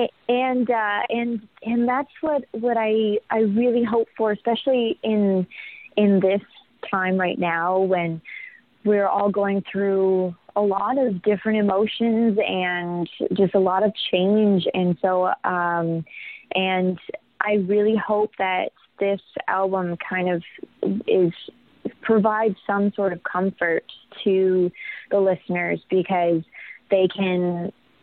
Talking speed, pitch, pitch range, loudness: 125 wpm, 200 Hz, 185-220 Hz, -22 LUFS